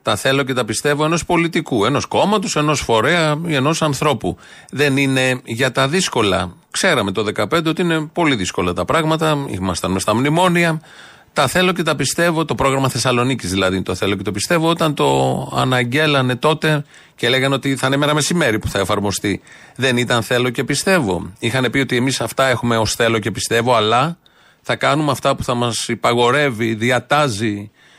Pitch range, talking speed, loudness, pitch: 115-155 Hz, 180 wpm, -17 LUFS, 135 Hz